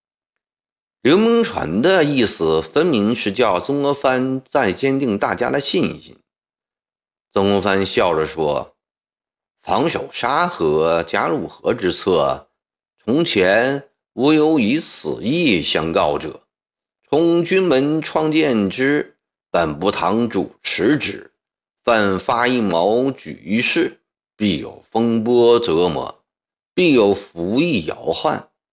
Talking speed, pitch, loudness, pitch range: 160 characters per minute, 130 Hz, -18 LUFS, 100-140 Hz